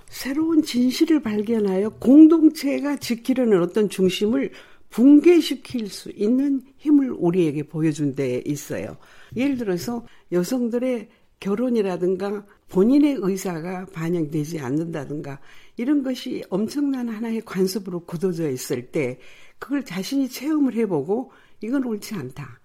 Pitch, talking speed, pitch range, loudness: 220 Hz, 290 characters per minute, 180-270 Hz, -22 LUFS